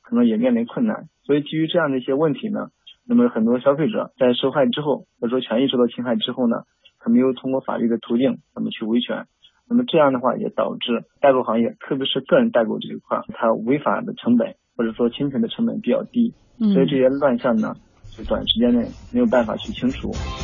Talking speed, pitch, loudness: 345 characters per minute, 160 Hz, -21 LUFS